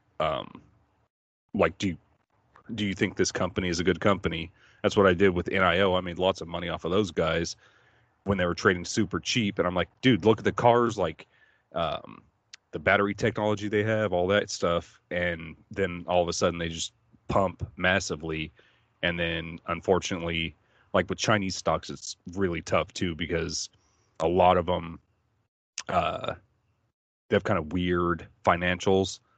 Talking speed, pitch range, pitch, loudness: 175 wpm, 85-105 Hz, 90 Hz, -27 LUFS